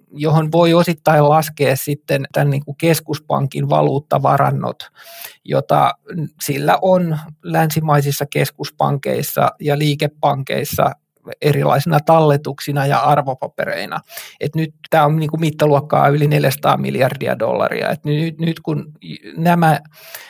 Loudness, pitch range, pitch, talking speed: -16 LUFS, 145-160 Hz, 150 Hz, 95 wpm